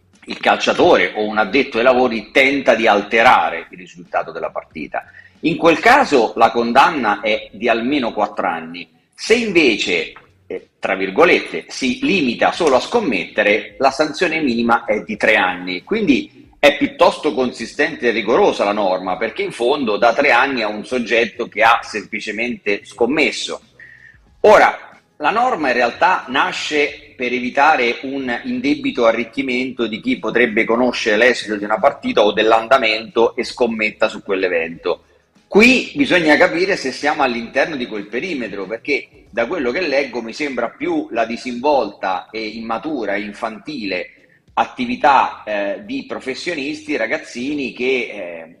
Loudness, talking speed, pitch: -16 LUFS, 145 wpm, 135 Hz